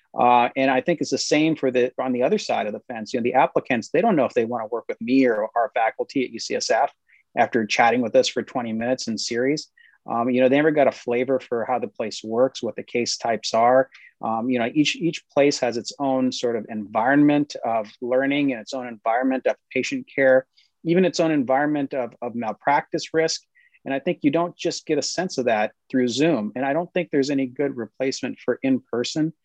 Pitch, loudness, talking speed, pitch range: 135 Hz, -22 LUFS, 235 wpm, 125-160 Hz